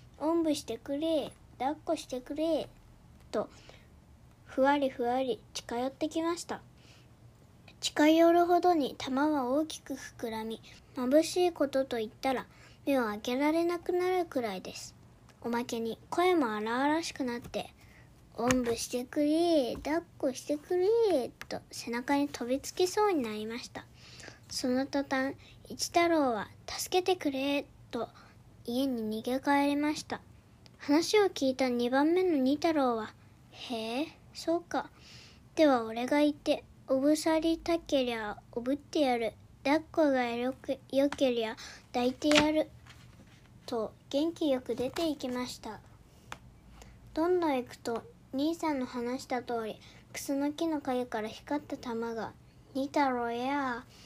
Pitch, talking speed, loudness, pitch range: 275 Hz, 260 characters per minute, -31 LUFS, 245-310 Hz